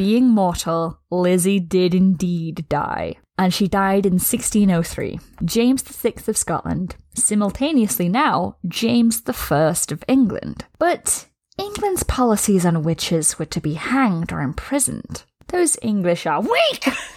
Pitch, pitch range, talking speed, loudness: 200 Hz, 175-240 Hz, 125 wpm, -19 LUFS